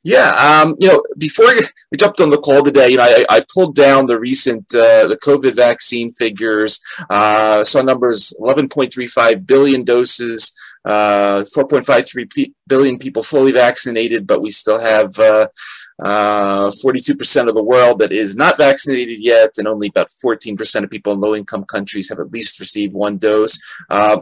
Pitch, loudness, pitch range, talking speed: 120 Hz, -13 LUFS, 105-135 Hz, 170 wpm